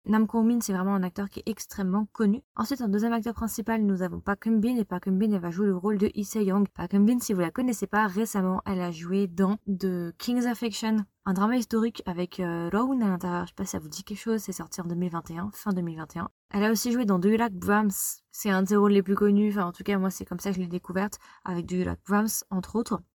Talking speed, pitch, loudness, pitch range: 265 wpm, 200 Hz, -27 LUFS, 185-220 Hz